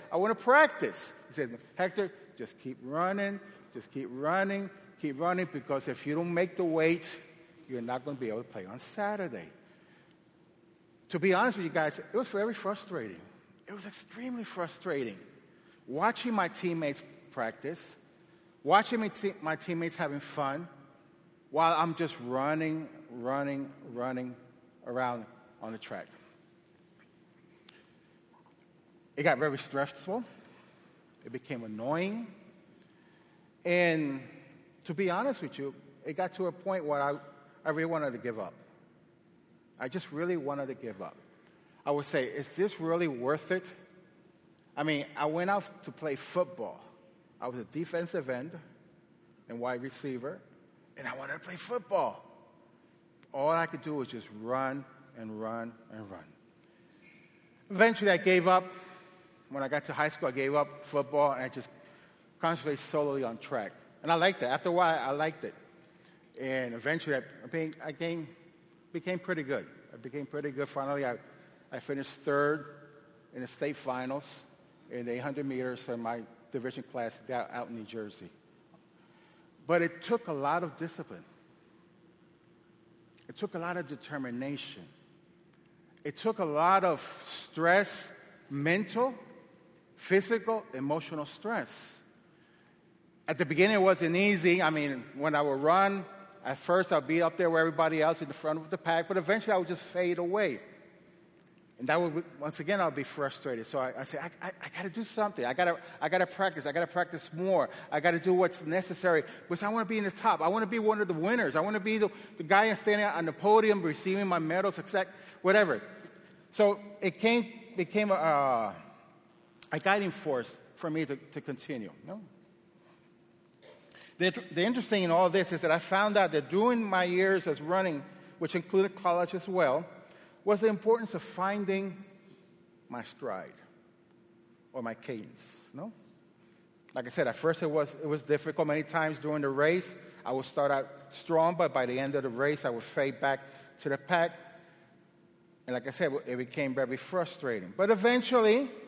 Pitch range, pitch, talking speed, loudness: 145-185 Hz, 170 Hz, 170 wpm, -31 LUFS